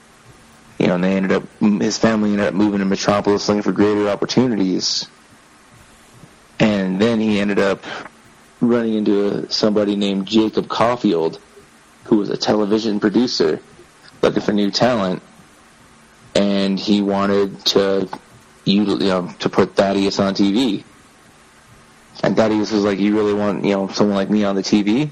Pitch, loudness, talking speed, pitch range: 100 Hz, -18 LUFS, 150 wpm, 100-105 Hz